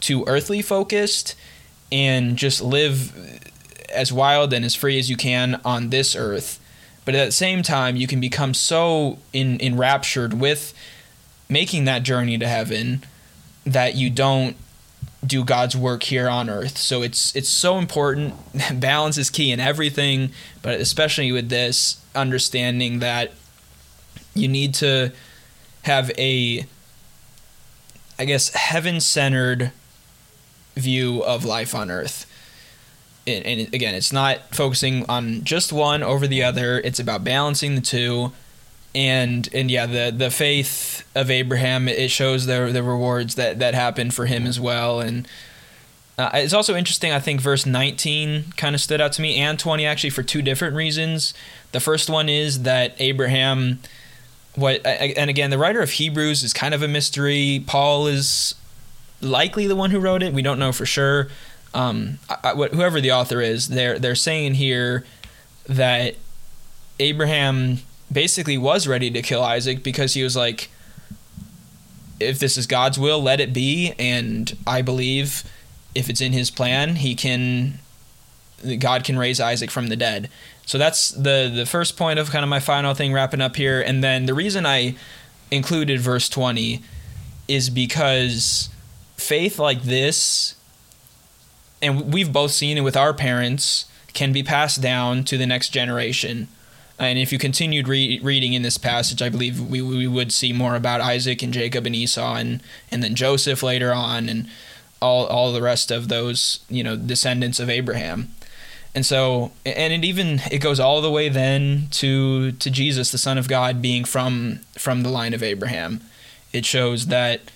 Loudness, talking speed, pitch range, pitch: -20 LUFS, 165 wpm, 125-140 Hz, 130 Hz